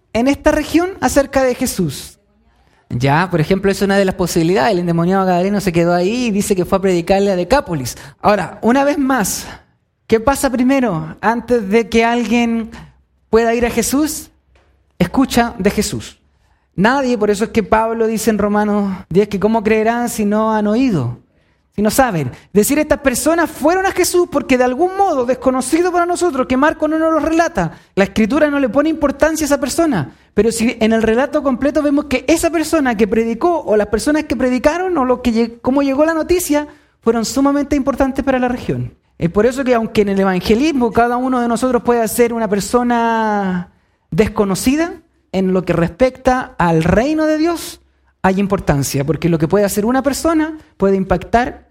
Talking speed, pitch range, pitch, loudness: 185 wpm, 200-280 Hz, 235 Hz, -15 LUFS